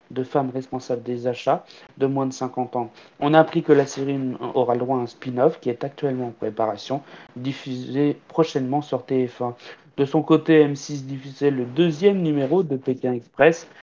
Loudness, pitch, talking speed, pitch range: -22 LUFS, 135 Hz, 180 wpm, 125-145 Hz